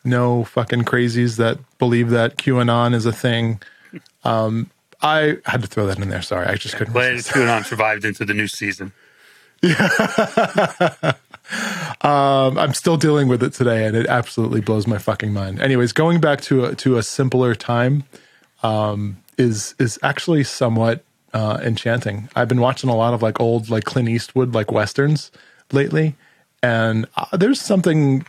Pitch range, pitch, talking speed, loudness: 110-135 Hz, 120 Hz, 165 wpm, -19 LUFS